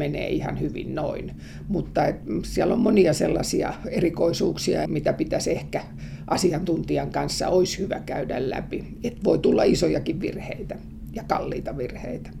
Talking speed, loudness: 135 wpm, -25 LUFS